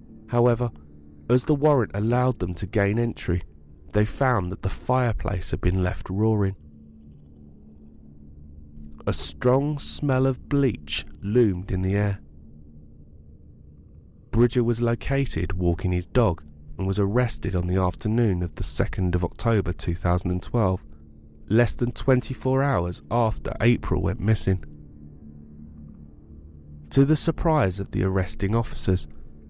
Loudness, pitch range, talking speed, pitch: -24 LUFS, 75-115 Hz, 120 wpm, 95 Hz